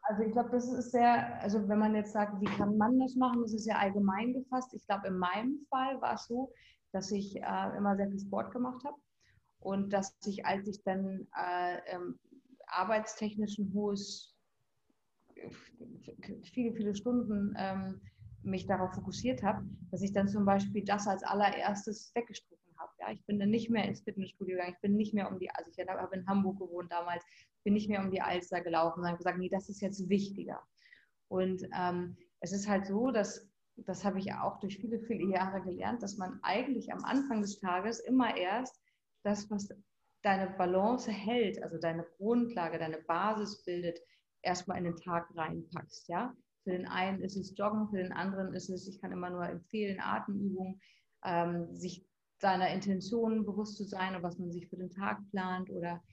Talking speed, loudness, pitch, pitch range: 190 wpm, -35 LUFS, 200 Hz, 185-215 Hz